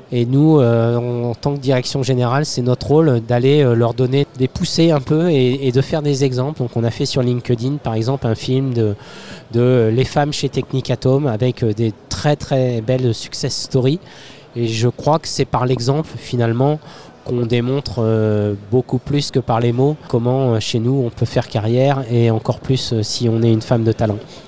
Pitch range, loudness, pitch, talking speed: 120-140 Hz, -17 LUFS, 130 Hz, 195 wpm